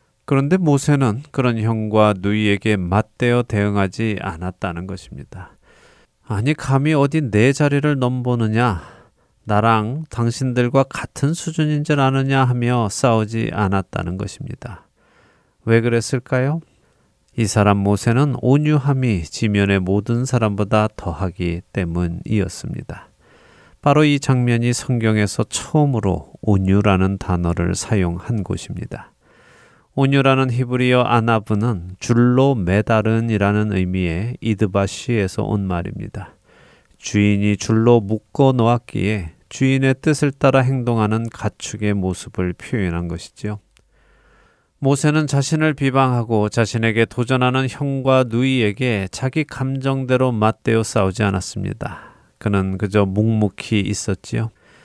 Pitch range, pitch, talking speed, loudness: 100-130 Hz, 115 Hz, 280 characters per minute, -18 LUFS